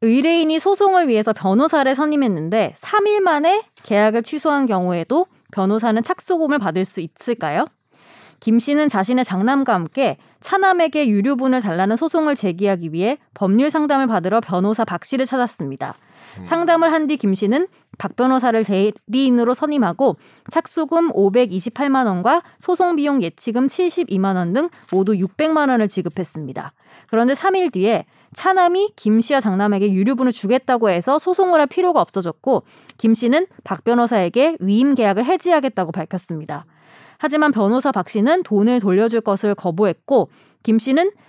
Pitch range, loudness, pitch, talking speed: 200-305 Hz, -18 LUFS, 245 Hz, 335 characters per minute